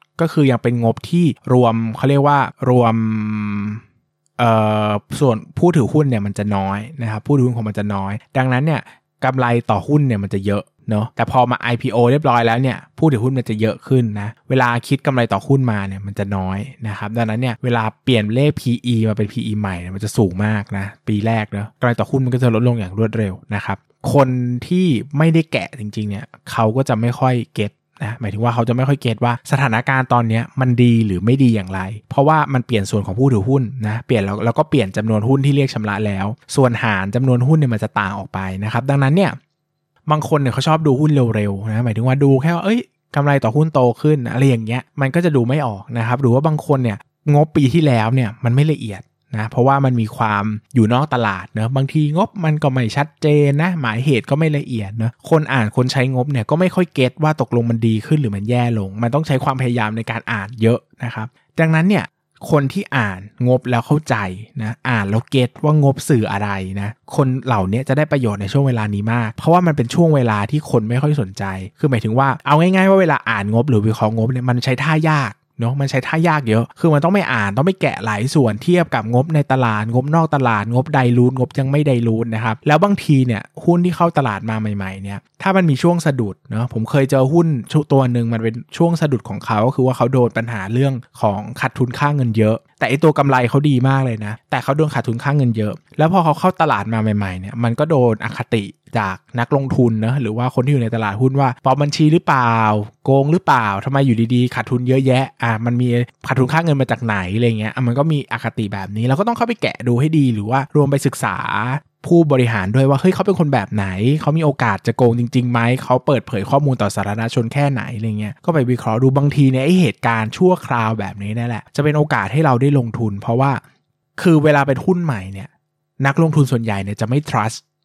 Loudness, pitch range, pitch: -17 LUFS, 110-145 Hz, 125 Hz